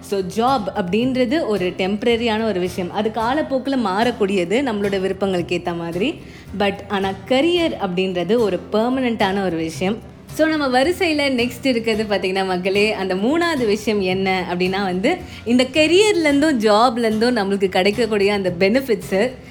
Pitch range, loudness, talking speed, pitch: 190-250 Hz, -19 LUFS, 125 wpm, 210 Hz